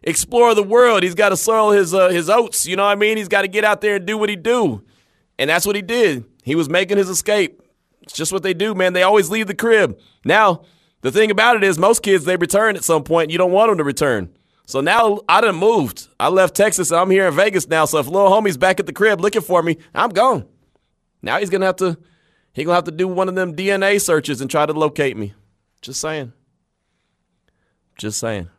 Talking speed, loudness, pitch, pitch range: 250 wpm, -16 LUFS, 185 Hz, 160-210 Hz